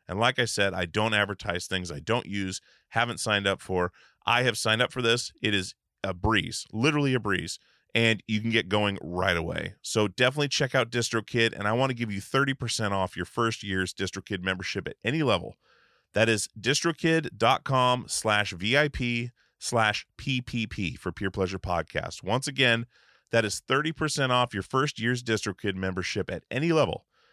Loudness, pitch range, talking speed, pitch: -27 LUFS, 95-125 Hz, 180 wpm, 110 Hz